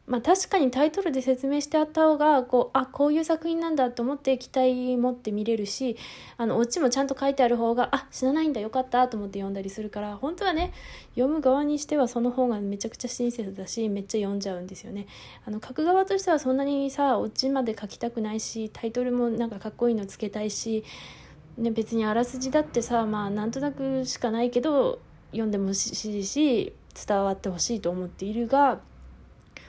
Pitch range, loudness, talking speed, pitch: 215-275 Hz, -26 LUFS, 350 characters per minute, 245 Hz